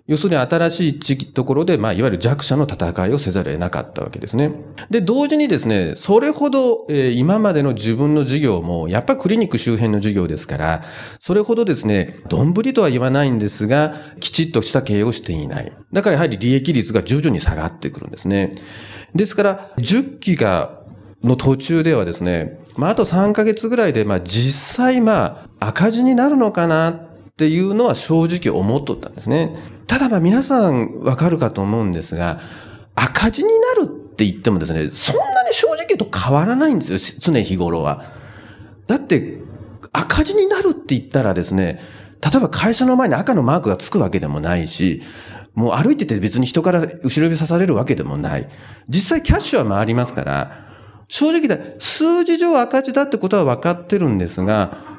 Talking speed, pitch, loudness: 370 characters per minute, 150 Hz, -17 LUFS